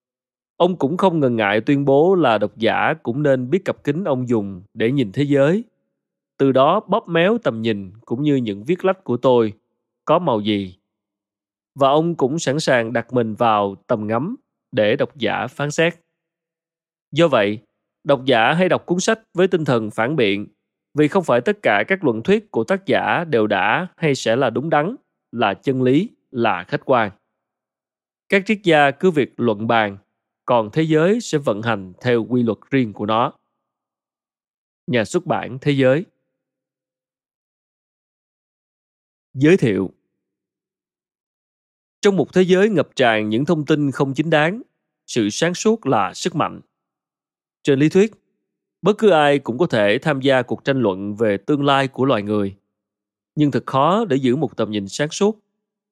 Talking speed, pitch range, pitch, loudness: 175 wpm, 115-165 Hz, 135 Hz, -19 LUFS